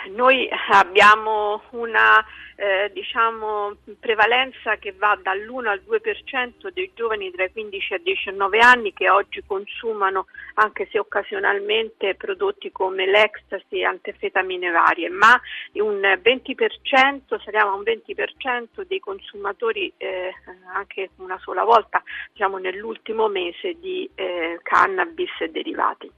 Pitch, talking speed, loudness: 235 Hz, 125 wpm, -20 LUFS